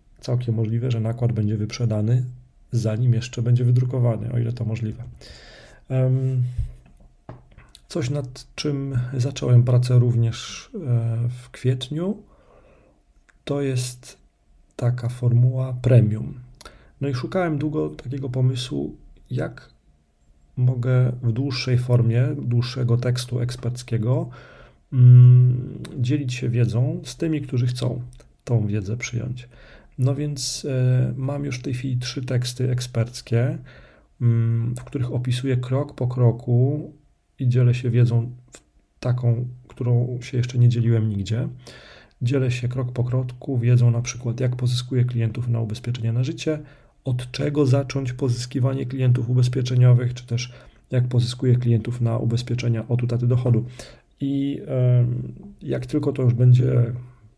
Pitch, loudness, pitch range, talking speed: 125 Hz, -22 LUFS, 120-130 Hz, 125 wpm